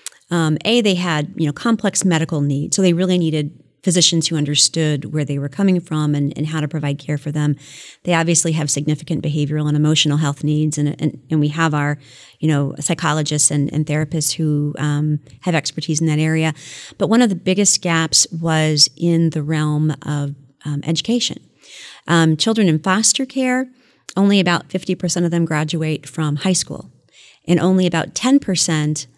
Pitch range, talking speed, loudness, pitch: 150-175 Hz, 185 wpm, -17 LUFS, 155 Hz